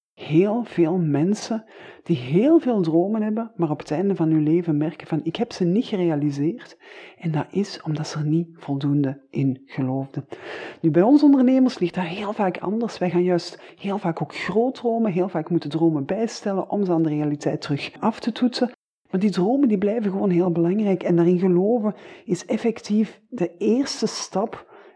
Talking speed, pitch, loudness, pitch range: 190 wpm, 180 Hz, -22 LUFS, 160-215 Hz